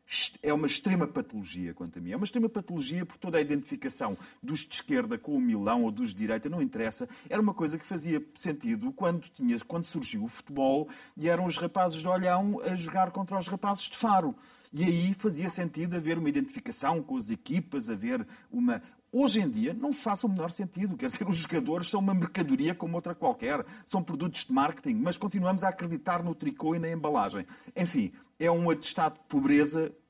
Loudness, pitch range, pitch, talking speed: -30 LUFS, 165-245 Hz, 190 Hz, 200 wpm